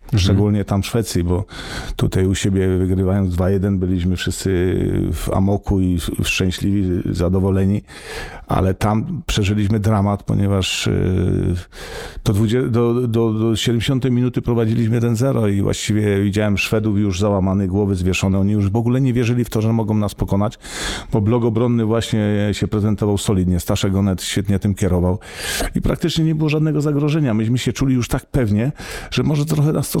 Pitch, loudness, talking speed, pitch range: 105 Hz, -18 LUFS, 160 wpm, 95-120 Hz